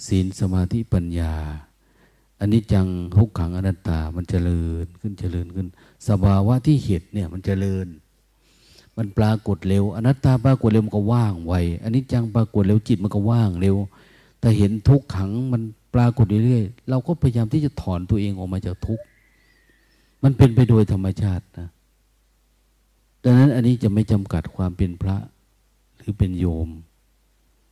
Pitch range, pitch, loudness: 90-115 Hz, 100 Hz, -21 LUFS